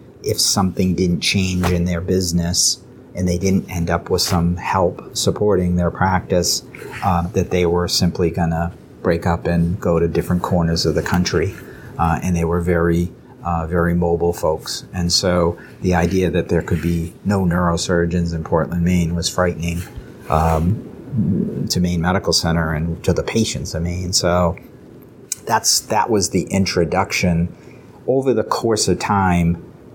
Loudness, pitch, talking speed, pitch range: -18 LUFS, 85 Hz, 160 wpm, 85-90 Hz